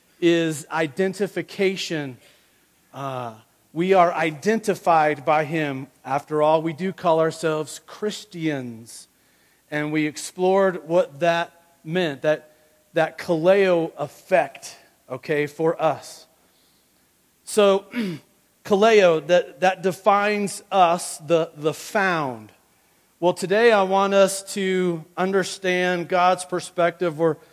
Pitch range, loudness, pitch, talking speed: 155-185 Hz, -22 LUFS, 170 Hz, 100 wpm